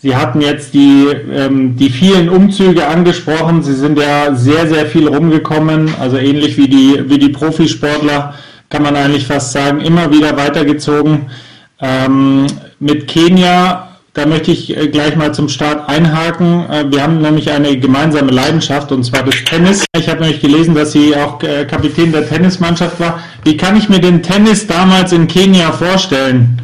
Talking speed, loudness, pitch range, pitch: 160 wpm, -10 LUFS, 145-165 Hz, 150 Hz